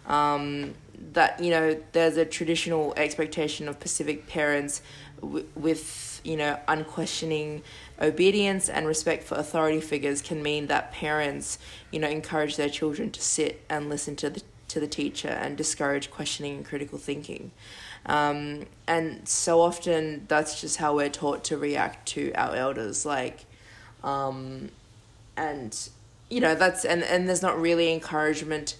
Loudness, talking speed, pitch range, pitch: -27 LUFS, 160 wpm, 145-160 Hz, 150 Hz